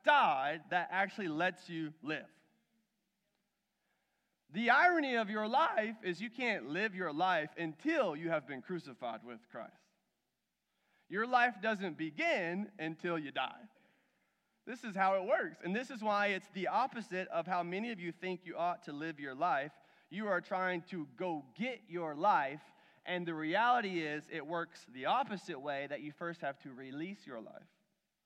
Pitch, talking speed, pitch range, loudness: 185 Hz, 170 wpm, 165-220 Hz, -36 LUFS